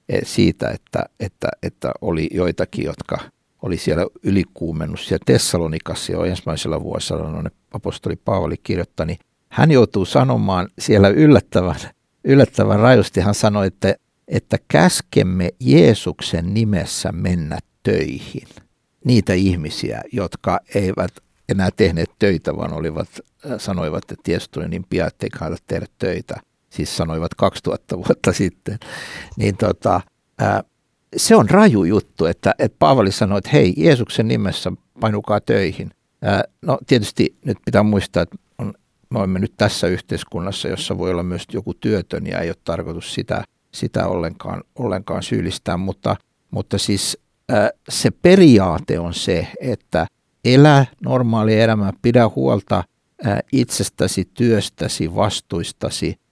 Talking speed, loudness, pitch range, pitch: 130 wpm, -18 LUFS, 90-110 Hz, 100 Hz